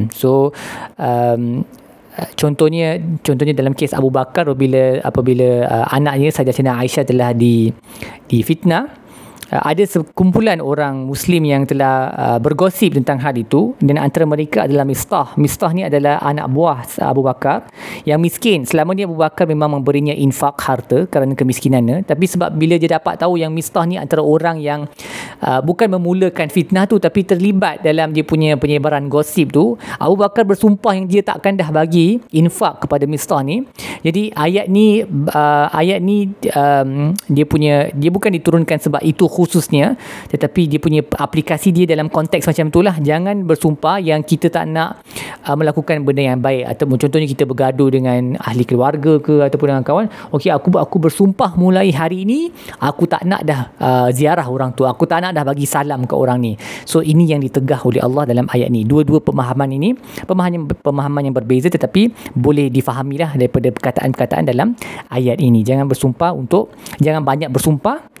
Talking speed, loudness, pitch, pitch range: 170 wpm, -15 LUFS, 150 Hz, 135-170 Hz